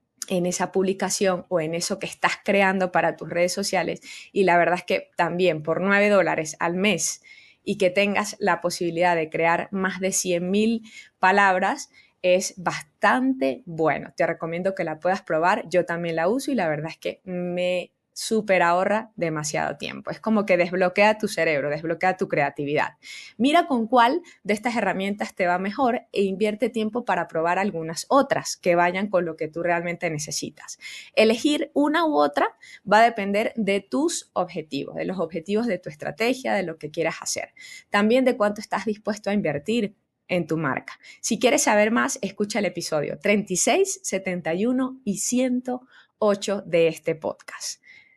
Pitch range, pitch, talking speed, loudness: 170-215 Hz, 190 Hz, 170 wpm, -23 LUFS